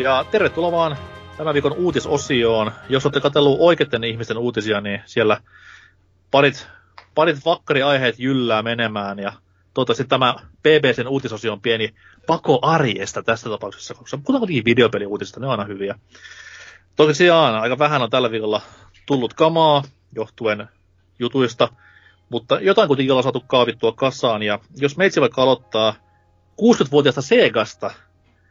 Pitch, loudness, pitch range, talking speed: 125 Hz, -18 LUFS, 105-145 Hz, 135 wpm